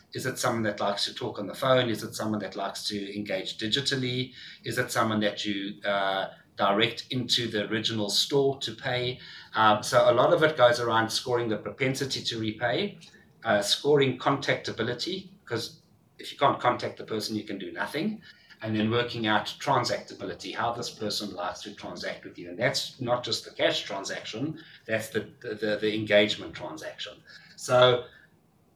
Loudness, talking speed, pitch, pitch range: -27 LUFS, 175 wpm, 115 Hz, 105-130 Hz